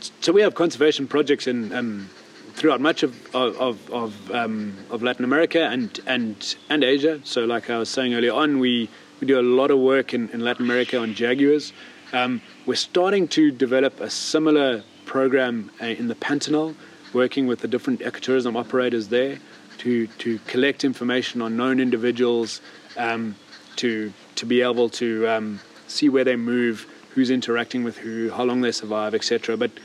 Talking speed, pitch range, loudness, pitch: 175 wpm, 115-135 Hz, -22 LUFS, 125 Hz